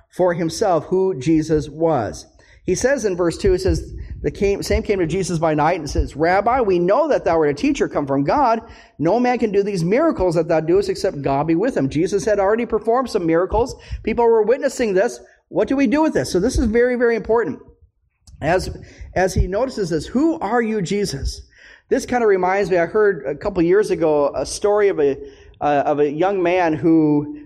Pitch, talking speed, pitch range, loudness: 195 Hz, 215 wpm, 165-230 Hz, -19 LUFS